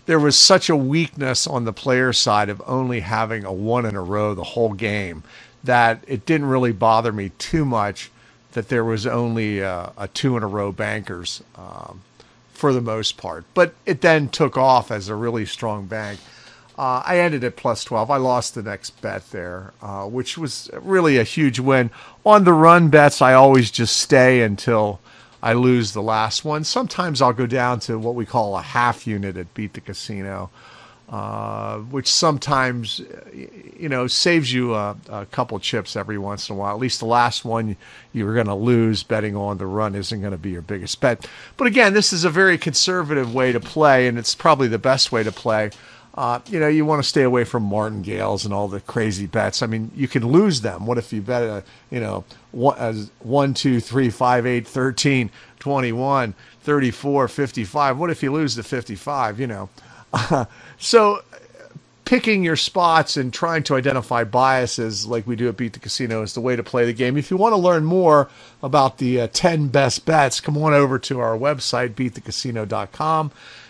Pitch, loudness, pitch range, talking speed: 120 Hz, -19 LUFS, 110-140 Hz, 200 wpm